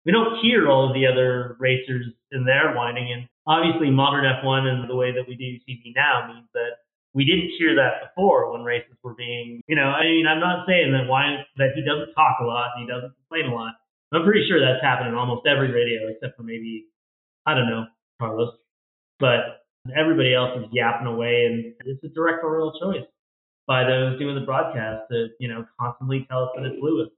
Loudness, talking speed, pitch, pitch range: -22 LUFS, 215 wpm, 130 Hz, 120-145 Hz